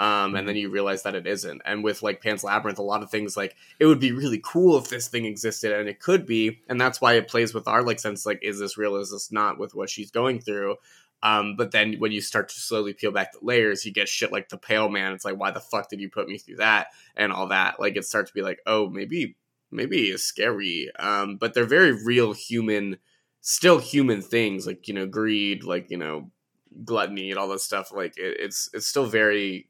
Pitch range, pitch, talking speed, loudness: 100-115 Hz, 105 Hz, 250 wpm, -24 LUFS